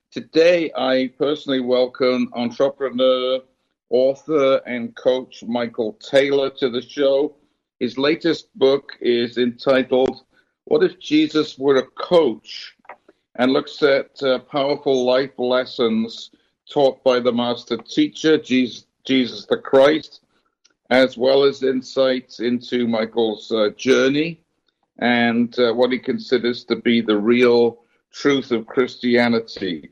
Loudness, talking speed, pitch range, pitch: -19 LUFS, 120 wpm, 120-140 Hz, 130 Hz